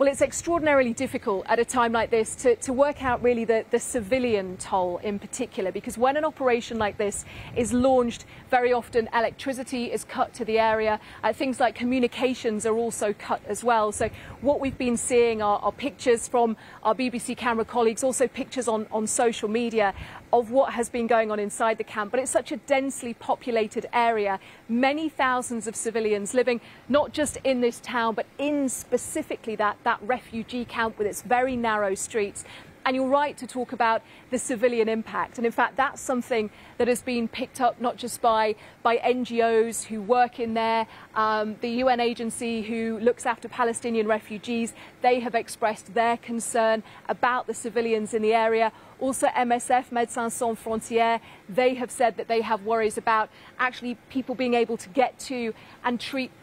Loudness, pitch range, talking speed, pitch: -25 LUFS, 225-250 Hz, 185 wpm, 235 Hz